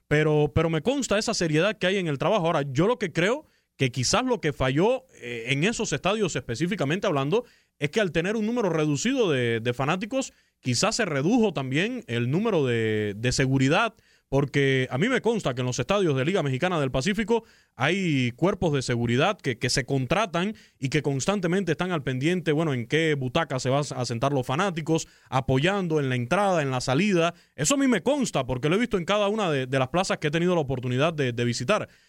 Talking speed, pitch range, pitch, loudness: 215 wpm, 135-200 Hz, 155 Hz, -25 LUFS